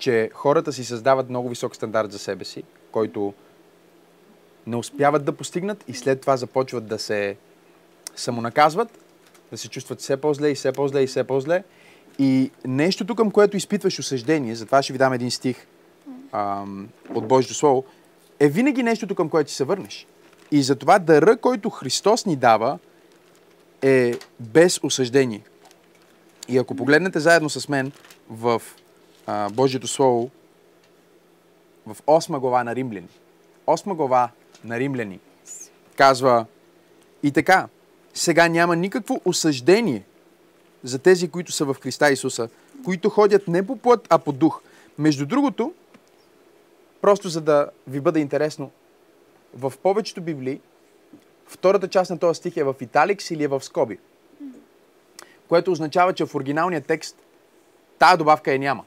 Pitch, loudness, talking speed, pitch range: 150 Hz, -21 LUFS, 145 wpm, 130-190 Hz